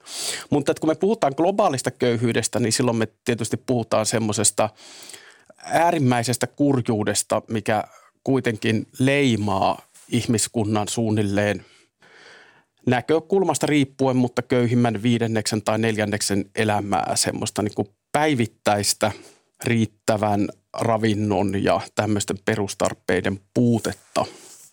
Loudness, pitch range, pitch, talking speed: -22 LUFS, 105-125 Hz, 115 Hz, 90 wpm